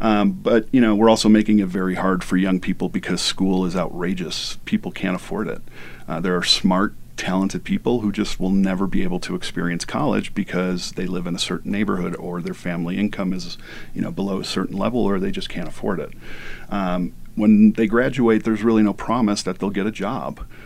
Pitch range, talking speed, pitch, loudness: 90-110 Hz, 210 wpm, 95 Hz, -21 LUFS